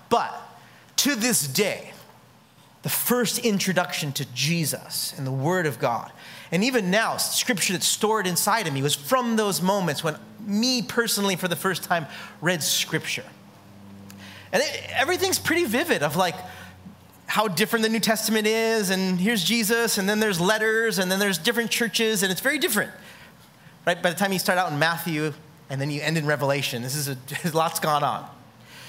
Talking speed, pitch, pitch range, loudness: 180 wpm, 185 Hz, 155-220 Hz, -23 LUFS